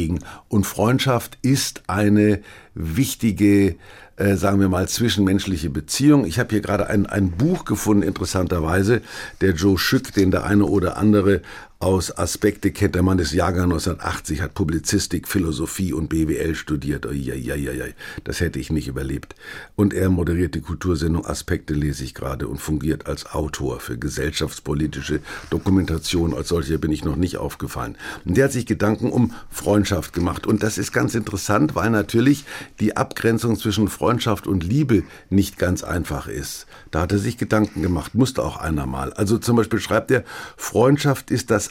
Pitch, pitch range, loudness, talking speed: 95 Hz, 85-105 Hz, -21 LUFS, 165 wpm